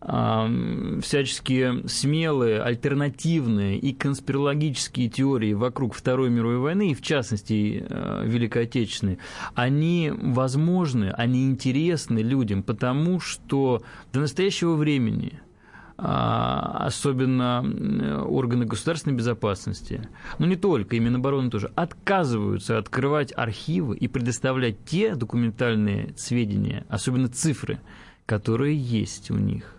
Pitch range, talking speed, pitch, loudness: 115-145 Hz, 105 wpm, 125 Hz, -25 LUFS